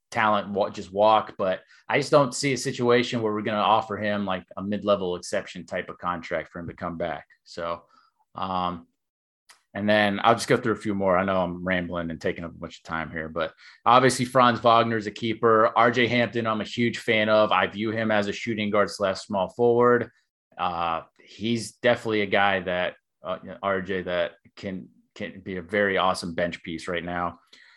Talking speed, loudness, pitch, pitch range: 205 wpm, -24 LUFS, 105 Hz, 95-115 Hz